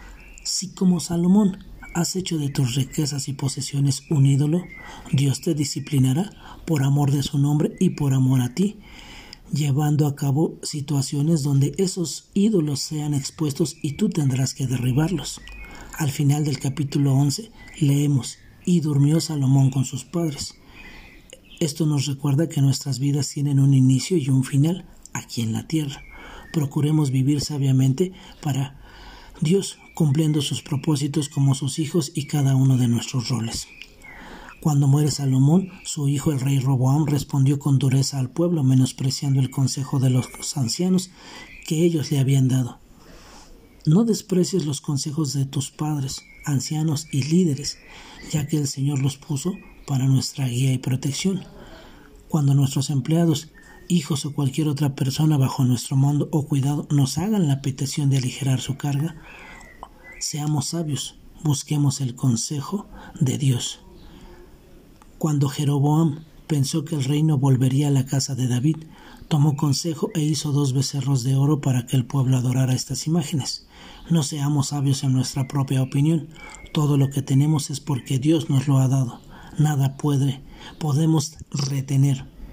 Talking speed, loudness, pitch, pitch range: 150 wpm, -22 LUFS, 145 Hz, 135-155 Hz